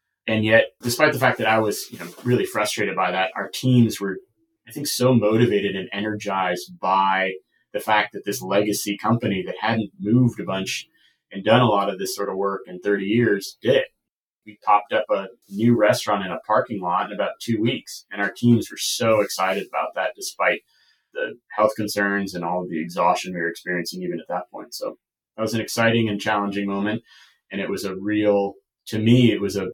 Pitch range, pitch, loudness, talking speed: 100-115 Hz, 105 Hz, -22 LUFS, 210 wpm